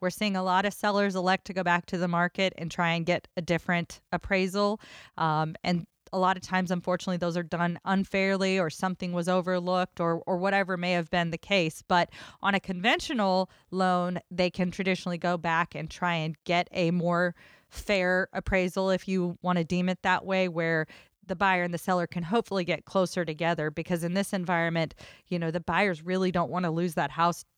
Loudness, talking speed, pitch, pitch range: -28 LUFS, 205 wpm, 180 Hz, 175-190 Hz